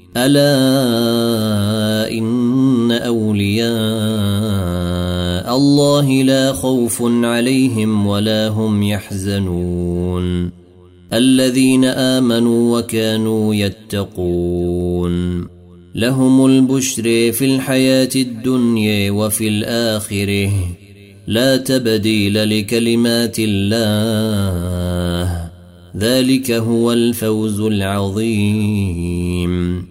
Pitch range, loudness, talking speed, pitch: 95-120 Hz, -15 LUFS, 60 wpm, 110 Hz